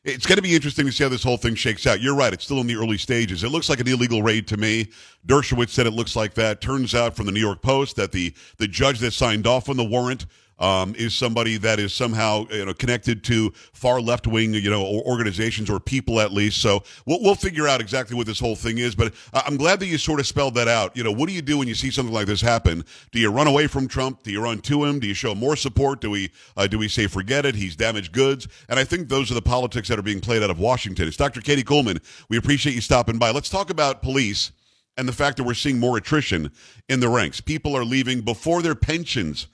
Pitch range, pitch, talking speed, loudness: 110-135 Hz, 120 Hz, 280 wpm, -22 LUFS